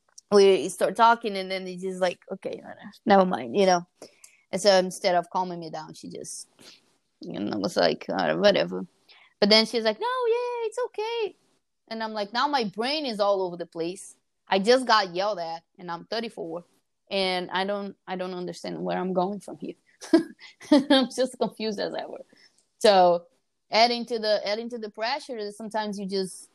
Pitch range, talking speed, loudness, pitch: 185-235 Hz, 195 wpm, -25 LUFS, 205 Hz